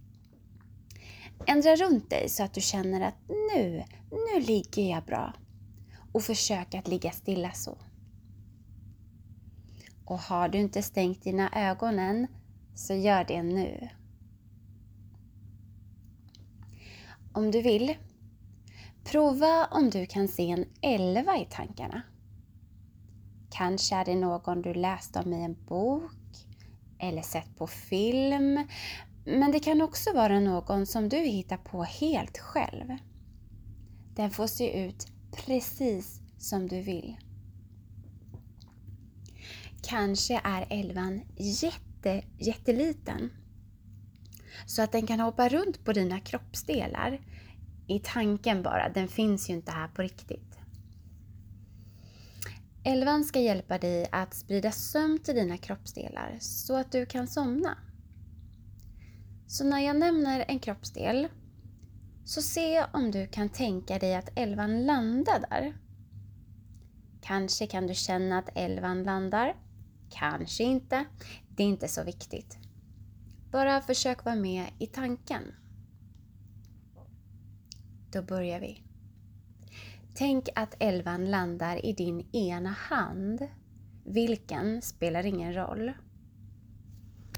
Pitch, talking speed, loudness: 175 Hz, 115 wpm, -30 LUFS